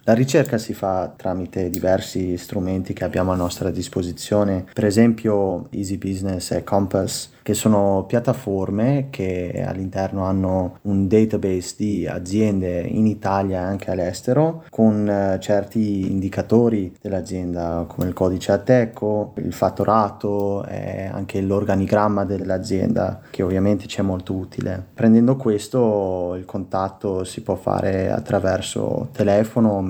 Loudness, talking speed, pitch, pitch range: -21 LUFS, 125 wpm, 100 Hz, 95-105 Hz